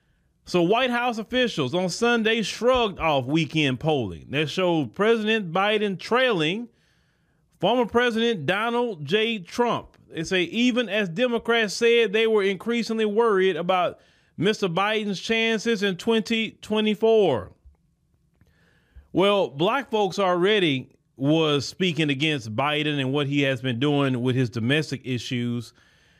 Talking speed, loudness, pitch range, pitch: 125 wpm, -23 LUFS, 150-225 Hz, 190 Hz